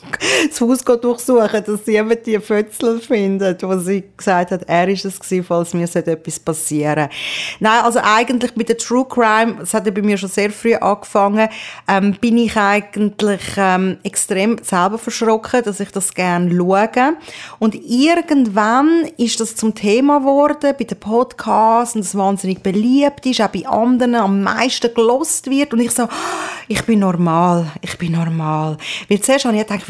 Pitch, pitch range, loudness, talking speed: 215 Hz, 195-235 Hz, -16 LUFS, 170 wpm